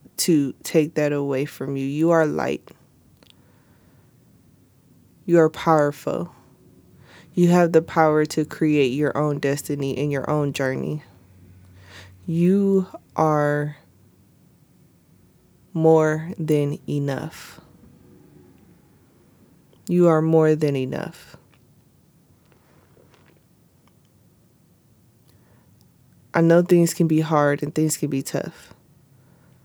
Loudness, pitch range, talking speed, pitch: -21 LUFS, 140-160 Hz, 95 wpm, 150 Hz